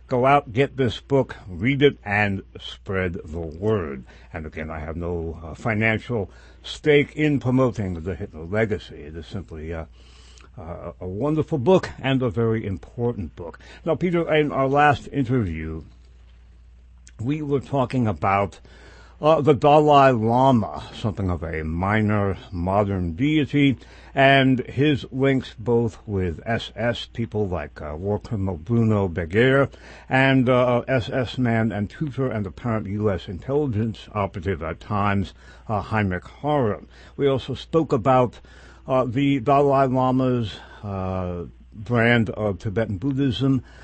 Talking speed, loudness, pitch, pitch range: 135 wpm, -22 LUFS, 110 Hz, 85-130 Hz